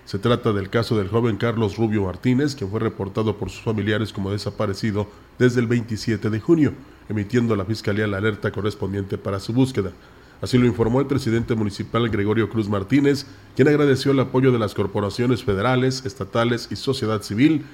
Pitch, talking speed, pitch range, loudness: 110 Hz, 180 wpm, 105-125 Hz, -22 LUFS